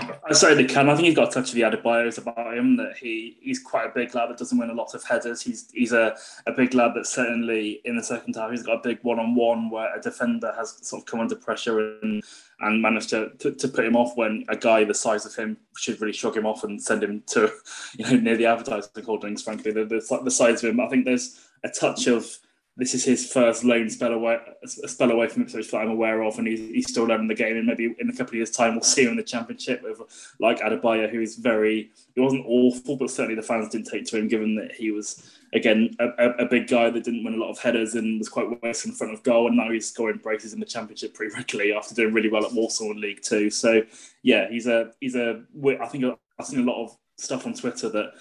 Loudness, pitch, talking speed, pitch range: -24 LUFS, 115 Hz, 270 wpm, 110-125 Hz